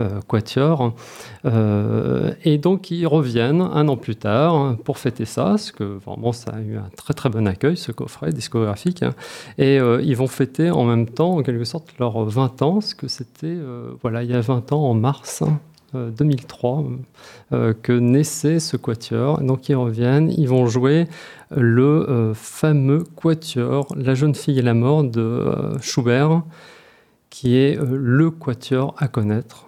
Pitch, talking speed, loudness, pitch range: 130 Hz, 175 wpm, -20 LUFS, 120-150 Hz